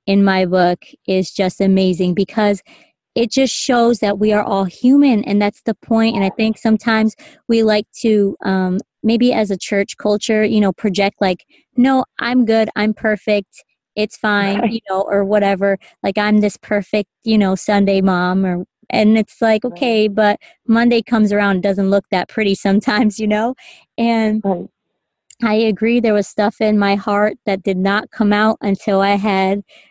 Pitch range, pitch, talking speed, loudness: 195-225 Hz, 210 Hz, 180 wpm, -16 LUFS